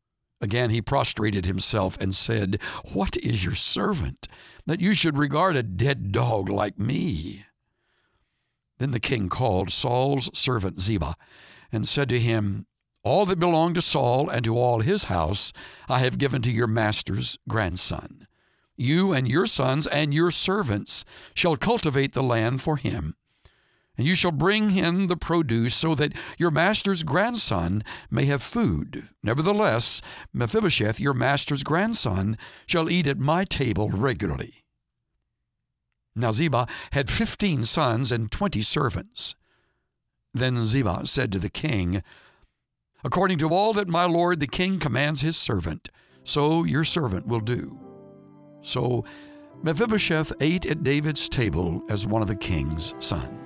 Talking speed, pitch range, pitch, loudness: 145 wpm, 110-160 Hz, 130 Hz, -24 LUFS